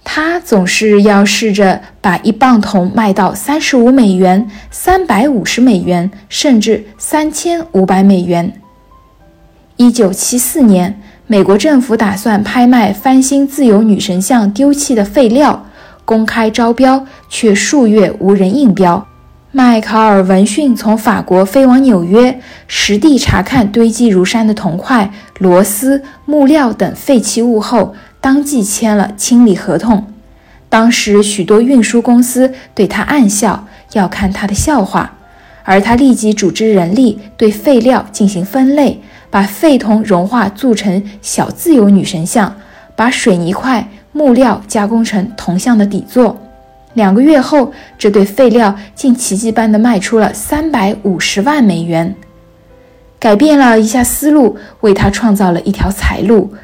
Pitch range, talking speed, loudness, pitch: 200-255 Hz, 220 characters per minute, -10 LUFS, 220 Hz